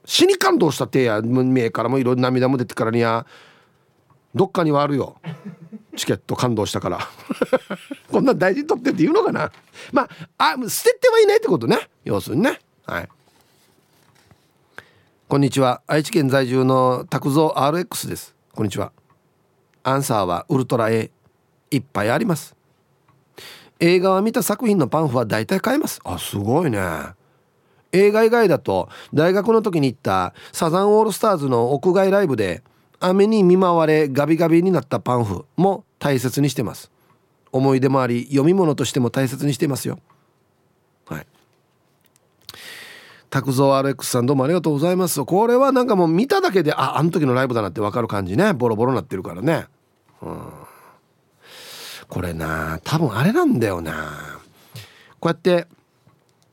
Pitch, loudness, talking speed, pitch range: 145 Hz, -19 LUFS, 325 characters per minute, 130-190 Hz